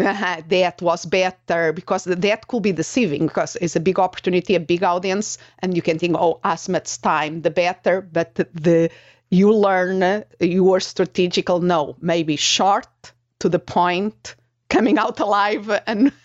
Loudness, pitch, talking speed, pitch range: -19 LUFS, 180 Hz, 165 wpm, 170-190 Hz